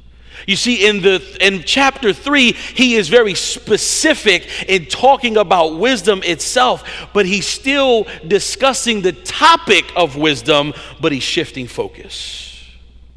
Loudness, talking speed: -13 LUFS, 130 wpm